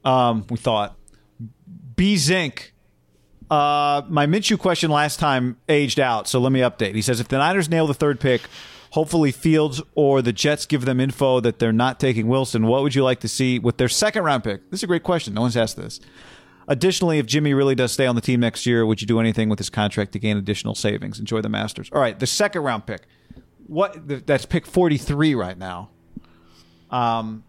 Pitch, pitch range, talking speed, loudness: 130 Hz, 115-150 Hz, 215 wpm, -20 LUFS